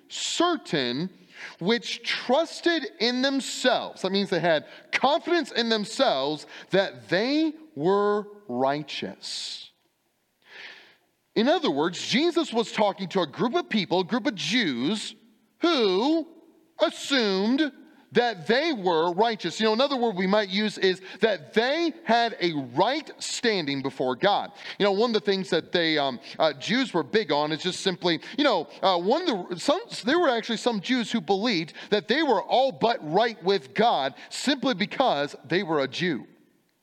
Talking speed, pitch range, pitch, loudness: 160 wpm, 190-275 Hz, 225 Hz, -25 LUFS